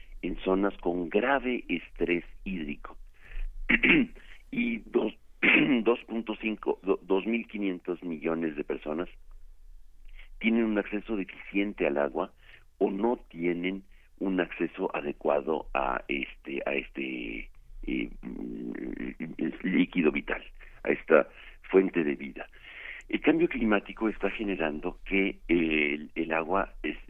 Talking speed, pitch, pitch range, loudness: 105 wpm, 90 Hz, 75-110 Hz, -29 LUFS